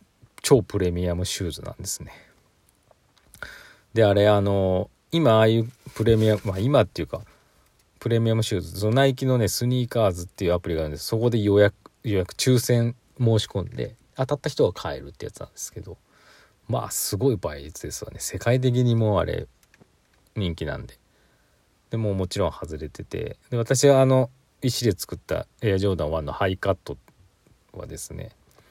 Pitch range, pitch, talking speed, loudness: 95-120 Hz, 110 Hz, 345 characters per minute, -24 LUFS